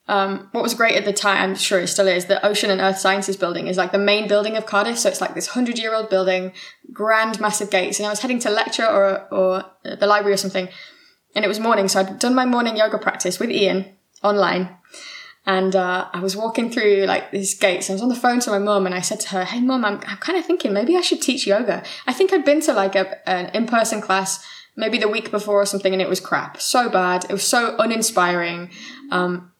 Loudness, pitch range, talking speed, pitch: -19 LUFS, 190-225 Hz, 250 wpm, 200 Hz